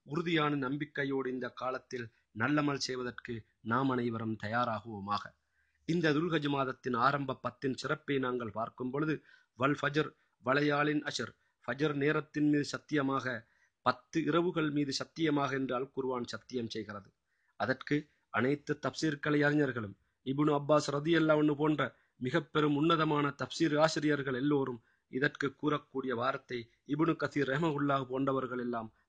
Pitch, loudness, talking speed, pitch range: 135 Hz, -33 LUFS, 120 wpm, 125-150 Hz